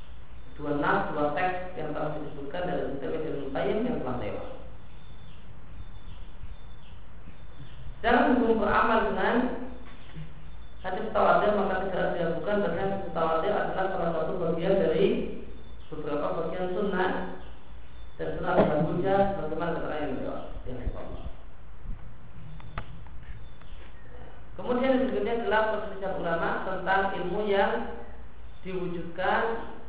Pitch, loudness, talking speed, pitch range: 180 Hz, -28 LUFS, 100 wpm, 150-205 Hz